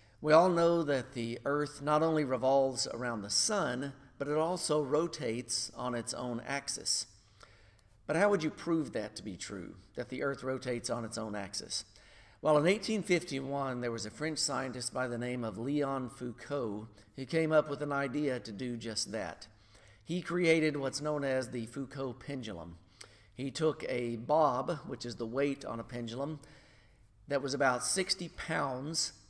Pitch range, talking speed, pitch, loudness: 115-150 Hz, 175 wpm, 135 Hz, -33 LUFS